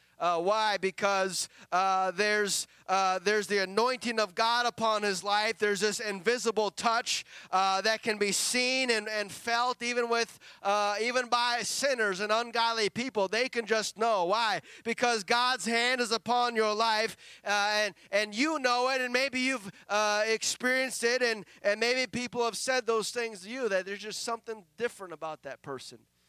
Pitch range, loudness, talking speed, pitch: 205-240 Hz, -29 LUFS, 175 wpm, 220 Hz